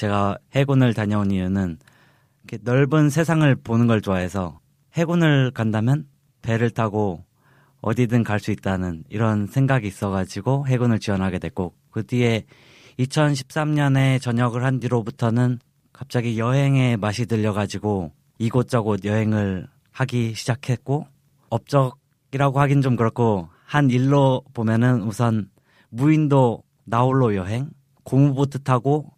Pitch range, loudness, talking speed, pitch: 110-135 Hz, -21 LUFS, 280 characters per minute, 125 Hz